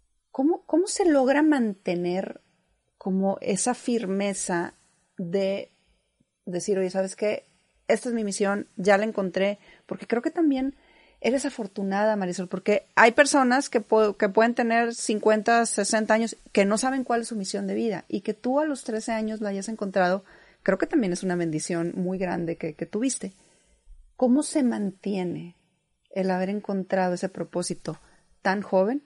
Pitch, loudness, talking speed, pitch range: 205 Hz, -25 LUFS, 160 wpm, 185-235 Hz